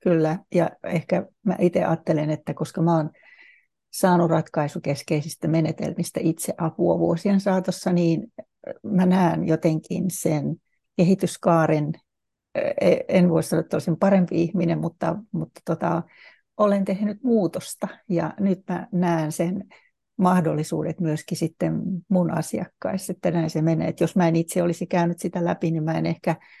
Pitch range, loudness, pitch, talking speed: 165-185 Hz, -23 LUFS, 170 Hz, 140 wpm